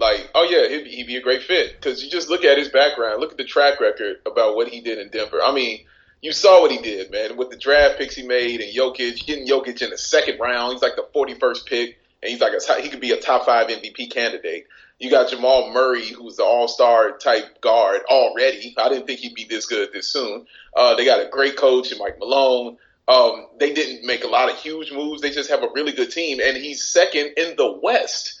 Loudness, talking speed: -19 LUFS, 245 wpm